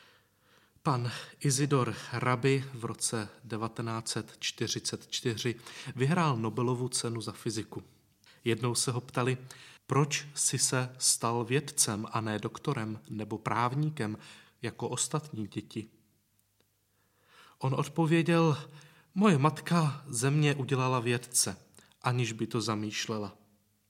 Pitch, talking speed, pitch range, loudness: 120 Hz, 100 wpm, 110-140 Hz, -31 LUFS